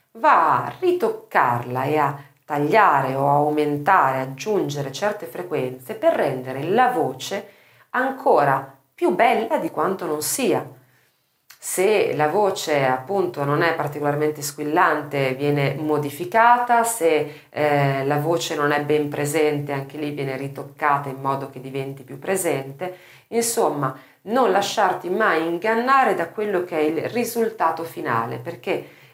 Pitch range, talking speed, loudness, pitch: 140-195 Hz, 130 wpm, -21 LUFS, 150 Hz